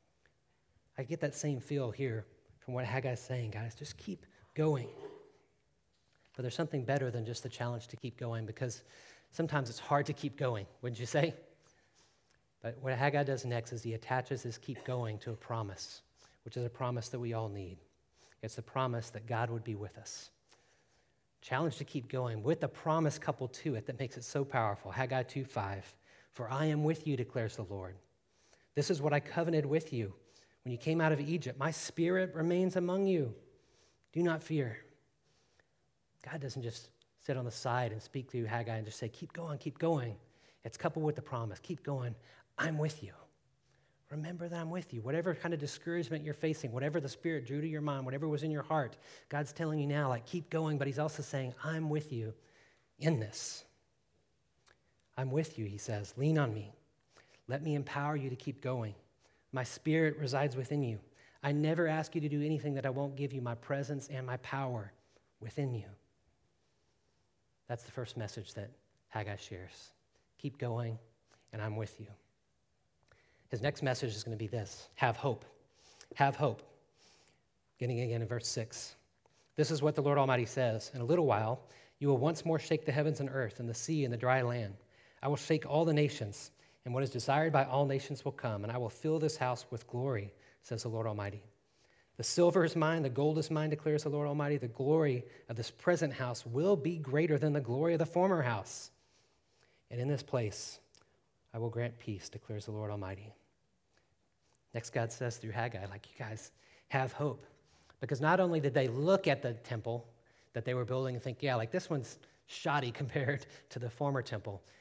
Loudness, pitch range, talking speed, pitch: -36 LUFS, 115-150 Hz, 200 wpm, 130 Hz